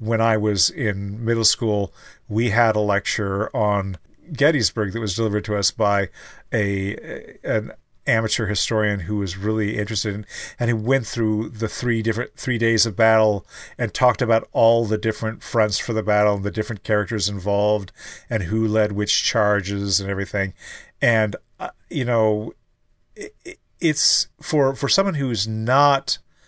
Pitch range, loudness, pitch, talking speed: 105-115 Hz, -21 LUFS, 110 Hz, 160 wpm